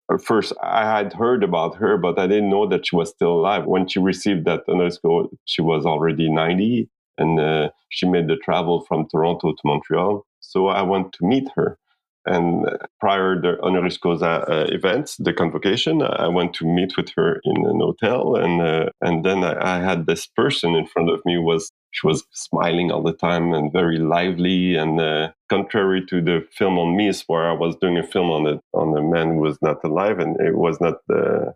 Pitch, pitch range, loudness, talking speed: 85 Hz, 80-95 Hz, -20 LUFS, 210 wpm